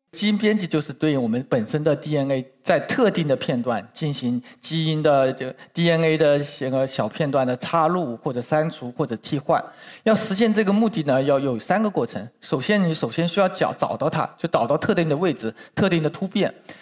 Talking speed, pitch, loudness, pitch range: 305 characters per minute, 155 Hz, -22 LUFS, 135-185 Hz